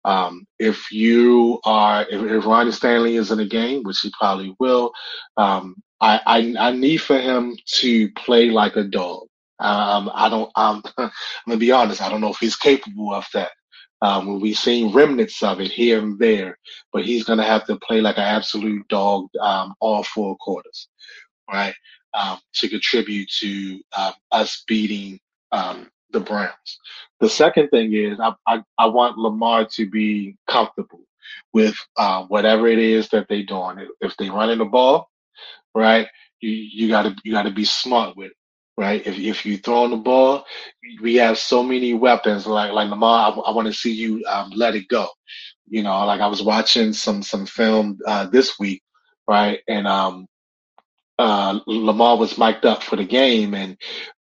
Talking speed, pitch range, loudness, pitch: 180 wpm, 105-115 Hz, -19 LUFS, 110 Hz